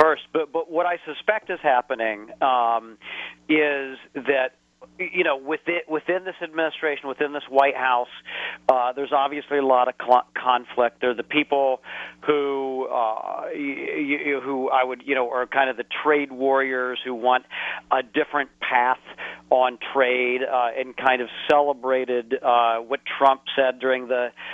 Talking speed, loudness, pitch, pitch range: 160 wpm, -23 LUFS, 135 Hz, 125-150 Hz